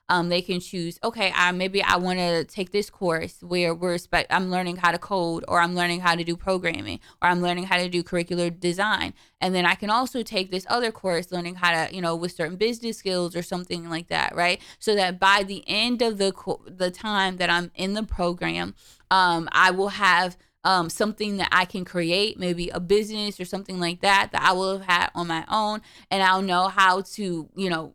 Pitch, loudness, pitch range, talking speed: 180 Hz, -24 LUFS, 175-195 Hz, 230 wpm